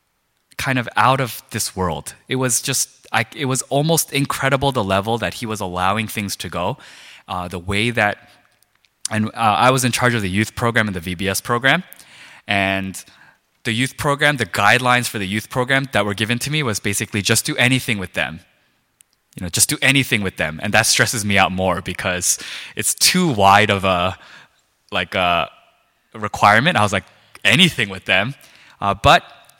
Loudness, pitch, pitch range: -18 LUFS, 110 Hz, 95-130 Hz